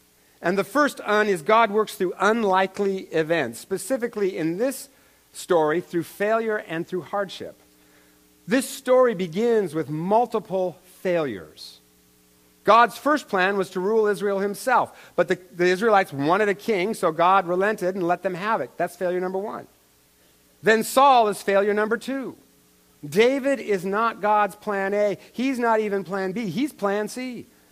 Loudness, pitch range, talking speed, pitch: -23 LUFS, 175-220 Hz, 155 wpm, 195 Hz